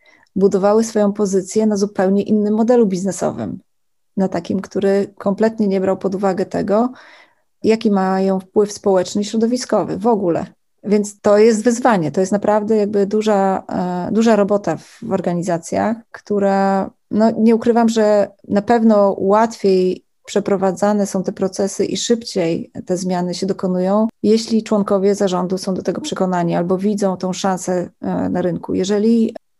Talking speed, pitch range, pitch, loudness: 145 wpm, 190-220 Hz, 200 Hz, -17 LUFS